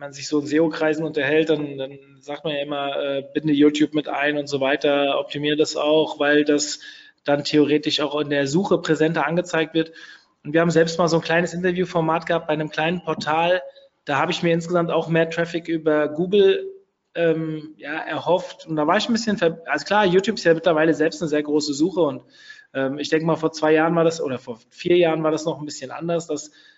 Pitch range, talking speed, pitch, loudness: 150-170 Hz, 230 wpm, 160 Hz, -21 LUFS